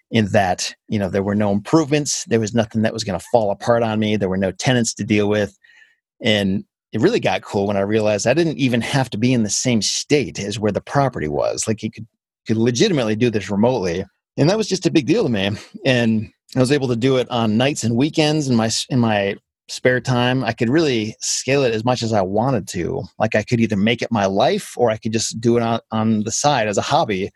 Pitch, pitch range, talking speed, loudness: 115 Hz, 105-130 Hz, 255 wpm, -19 LUFS